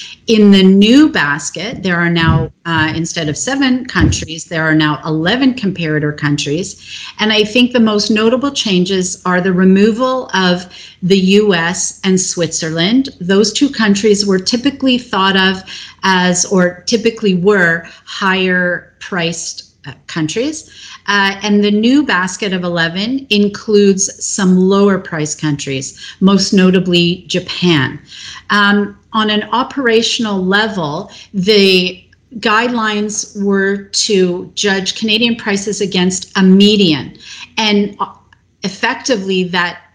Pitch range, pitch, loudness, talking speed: 180-215 Hz, 195 Hz, -13 LUFS, 120 wpm